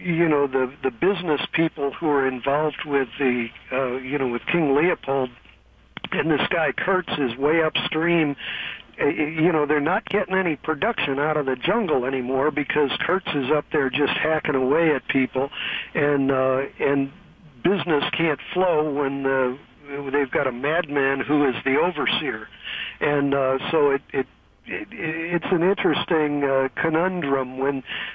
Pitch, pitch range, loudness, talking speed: 145 Hz, 135-160 Hz, -23 LUFS, 160 wpm